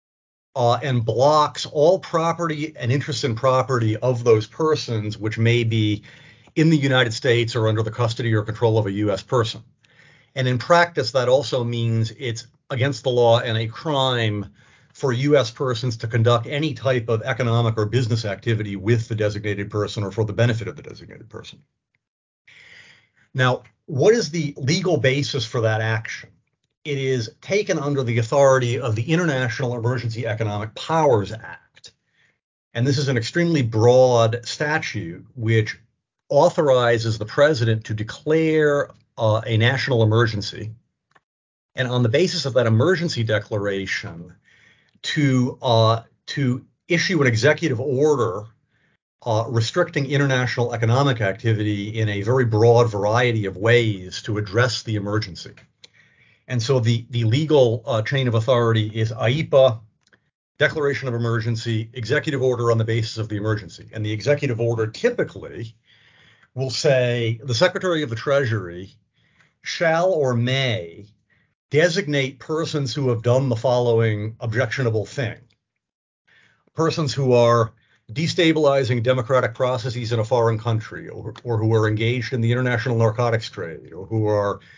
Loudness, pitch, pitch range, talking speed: -21 LUFS, 120 Hz, 110-135 Hz, 145 wpm